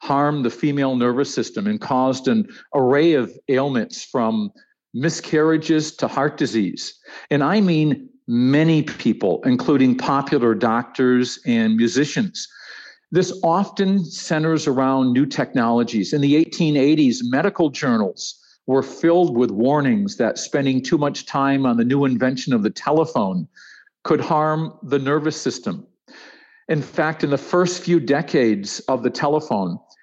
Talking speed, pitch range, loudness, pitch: 135 wpm, 135-180 Hz, -19 LUFS, 155 Hz